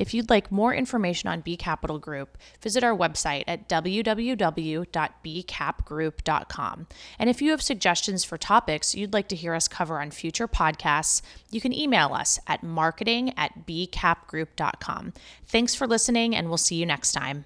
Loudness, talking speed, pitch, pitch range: -25 LUFS, 160 wpm, 175 Hz, 160-230 Hz